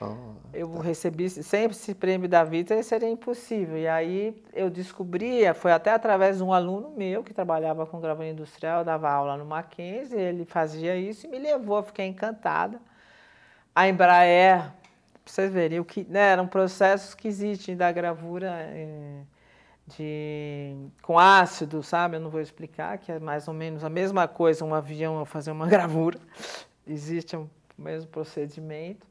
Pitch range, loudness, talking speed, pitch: 160-195 Hz, -25 LUFS, 155 wpm, 175 Hz